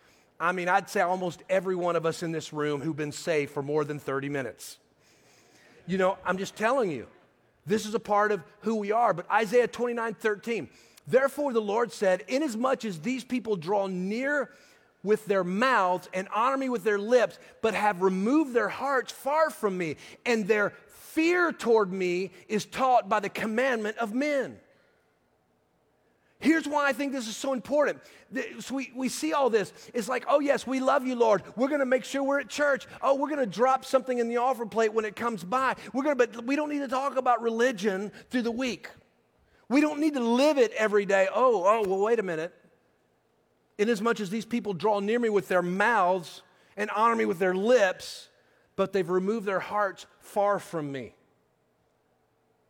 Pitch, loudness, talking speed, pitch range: 225 Hz, -27 LUFS, 195 wpm, 190-260 Hz